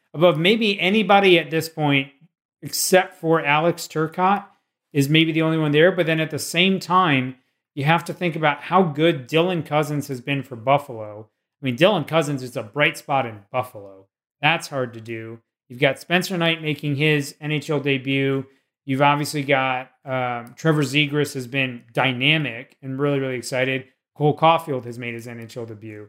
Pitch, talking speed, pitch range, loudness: 145 Hz, 175 wpm, 130-165 Hz, -20 LUFS